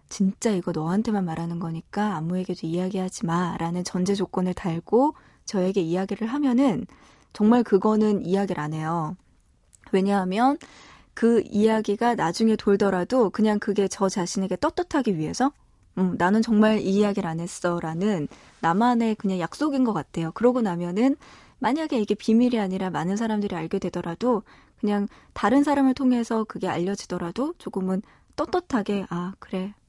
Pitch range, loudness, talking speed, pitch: 180-225 Hz, -24 LUFS, 345 characters per minute, 200 Hz